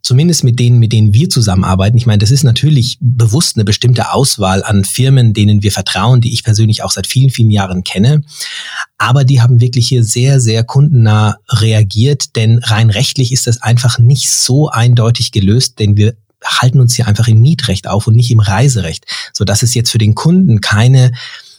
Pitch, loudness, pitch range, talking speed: 115 Hz, -10 LUFS, 110-130 Hz, 195 wpm